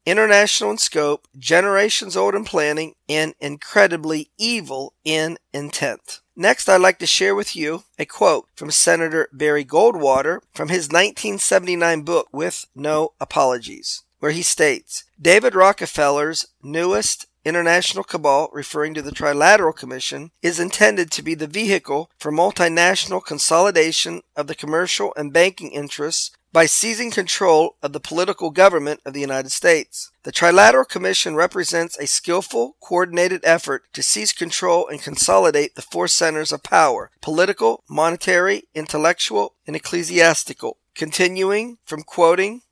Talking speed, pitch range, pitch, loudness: 135 wpm, 150-185 Hz, 165 Hz, -18 LUFS